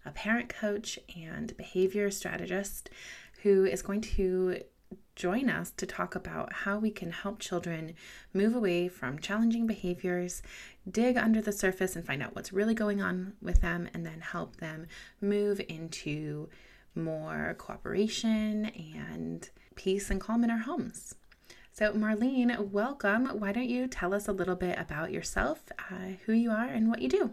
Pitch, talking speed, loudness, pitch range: 200 Hz, 160 wpm, -32 LUFS, 175-215 Hz